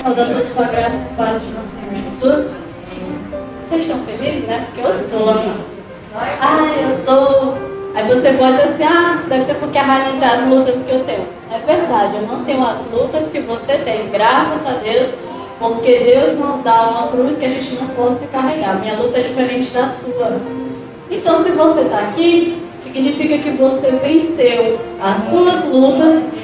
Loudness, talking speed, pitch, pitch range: -15 LUFS, 185 wpm, 260 Hz, 240-290 Hz